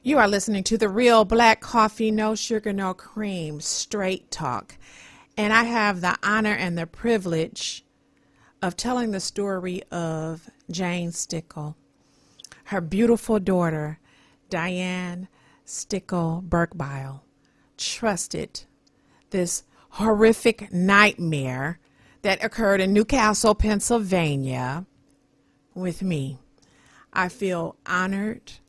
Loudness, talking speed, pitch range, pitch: -23 LUFS, 100 wpm, 165-215 Hz, 190 Hz